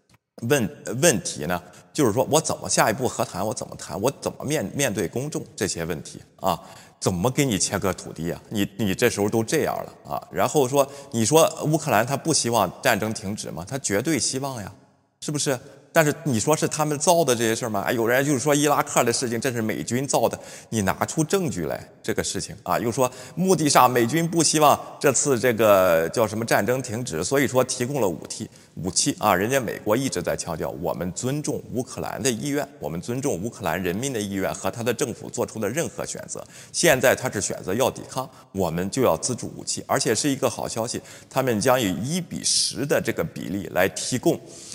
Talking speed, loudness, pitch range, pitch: 315 characters per minute, -23 LUFS, 110-145 Hz, 130 Hz